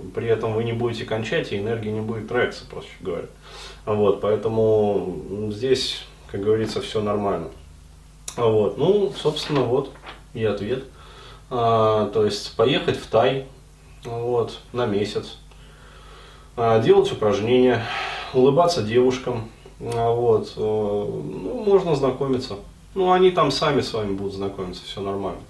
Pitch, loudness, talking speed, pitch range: 115 Hz, -22 LUFS, 125 wpm, 105-130 Hz